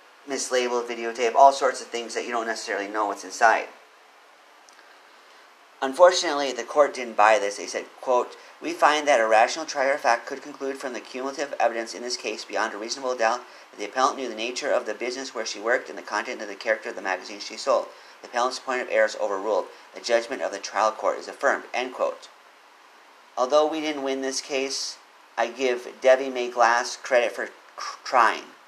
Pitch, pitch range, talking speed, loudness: 130 Hz, 115-140 Hz, 205 wpm, -24 LUFS